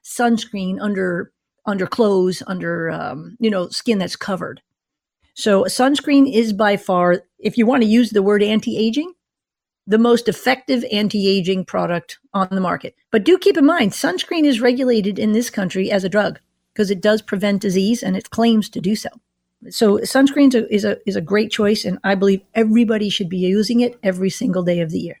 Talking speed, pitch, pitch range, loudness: 200 wpm, 210 Hz, 195-235 Hz, -18 LUFS